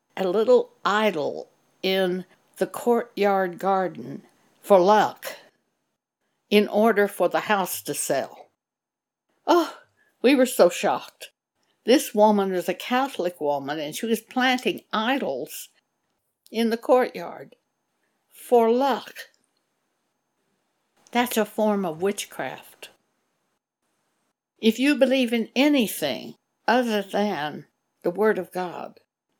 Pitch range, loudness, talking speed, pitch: 190-255 Hz, -23 LUFS, 110 wpm, 215 Hz